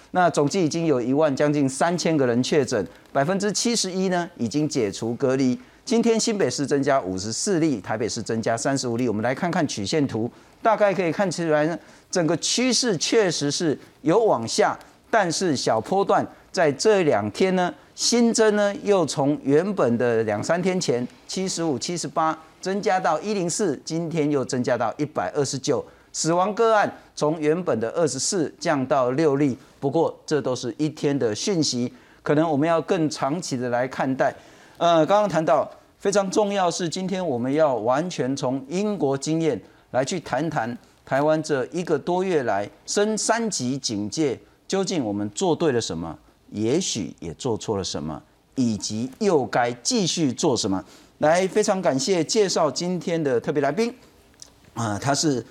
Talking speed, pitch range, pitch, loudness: 255 characters per minute, 135-190 Hz, 155 Hz, -23 LUFS